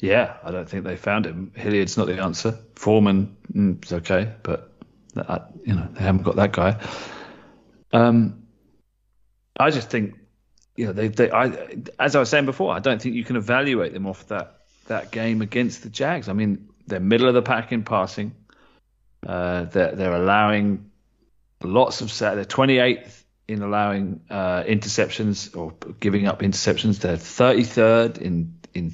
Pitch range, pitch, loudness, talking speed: 95-115 Hz, 105 Hz, -22 LUFS, 170 wpm